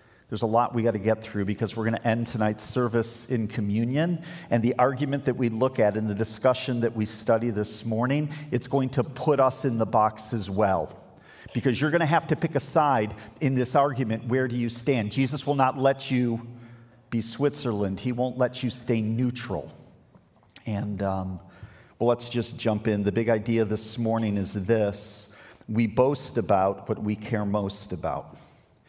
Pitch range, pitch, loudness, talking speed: 110-130 Hz, 115 Hz, -26 LUFS, 195 wpm